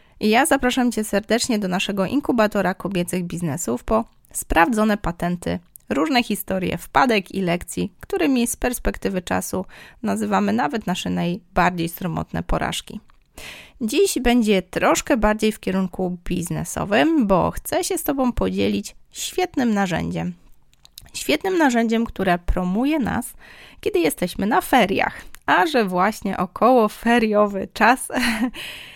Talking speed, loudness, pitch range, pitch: 120 wpm, -21 LUFS, 180-245 Hz, 215 Hz